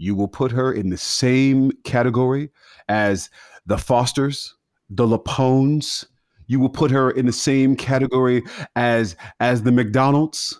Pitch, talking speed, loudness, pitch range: 130 Hz, 140 wpm, -19 LUFS, 120-135 Hz